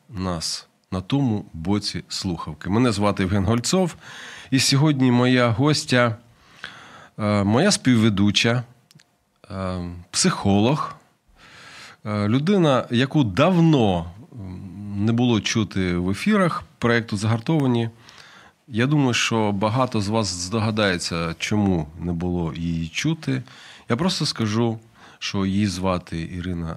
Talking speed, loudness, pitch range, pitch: 100 wpm, -21 LUFS, 95-125 Hz, 110 Hz